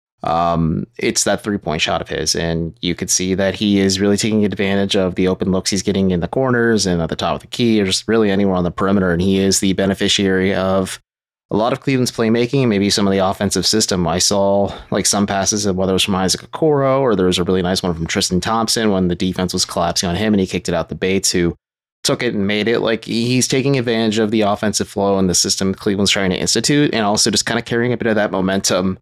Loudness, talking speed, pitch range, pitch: -16 LUFS, 260 wpm, 95-110 Hz, 100 Hz